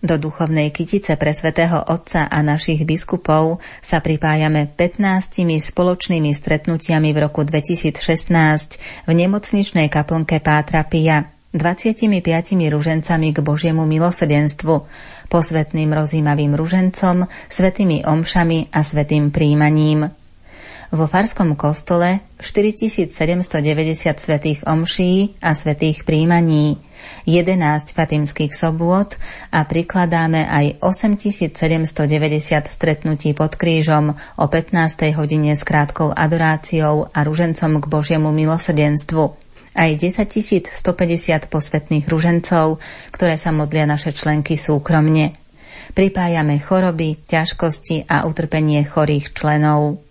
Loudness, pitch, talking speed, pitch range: -17 LUFS, 160 Hz, 100 wpm, 150-170 Hz